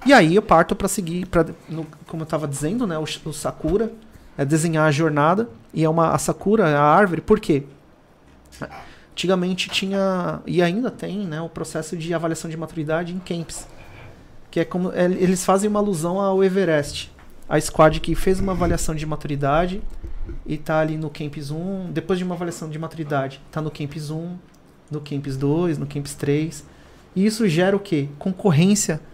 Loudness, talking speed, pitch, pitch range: -21 LUFS, 180 wpm, 165 Hz, 150-185 Hz